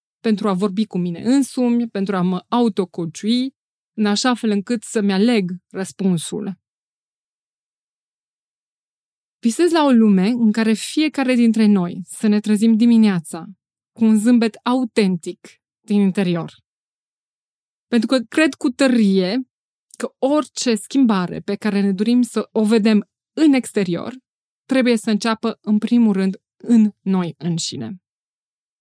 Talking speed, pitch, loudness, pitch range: 130 wpm, 220 Hz, -18 LUFS, 195-240 Hz